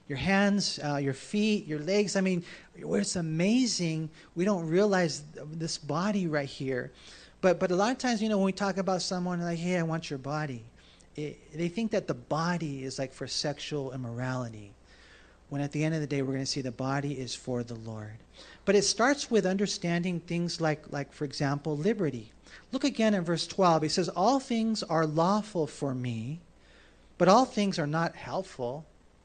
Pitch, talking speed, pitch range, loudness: 165 Hz, 195 wpm, 140-195 Hz, -30 LUFS